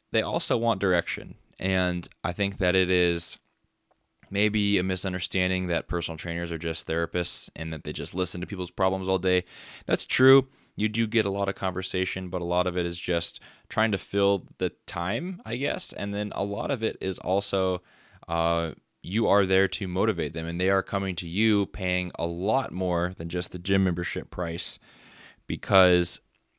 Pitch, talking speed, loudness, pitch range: 90 Hz, 190 wpm, -27 LUFS, 85-100 Hz